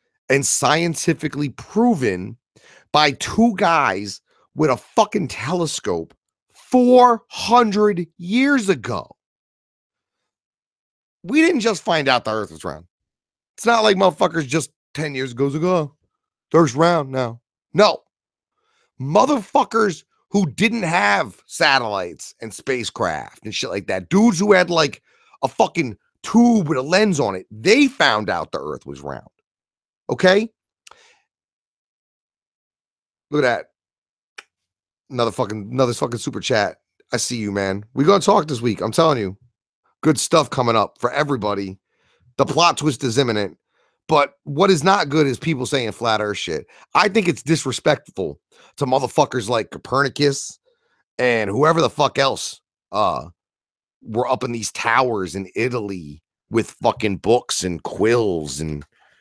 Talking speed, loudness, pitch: 140 wpm, -19 LUFS, 145 Hz